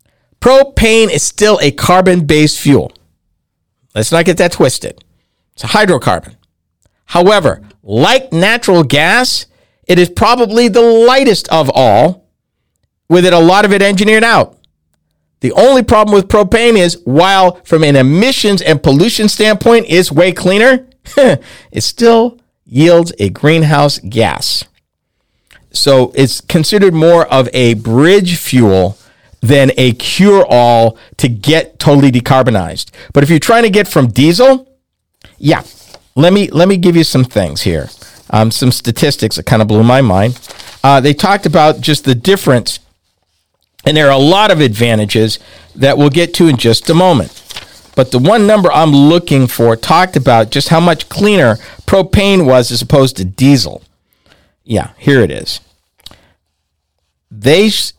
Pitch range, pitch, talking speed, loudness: 115-185 Hz, 145 Hz, 150 wpm, -9 LUFS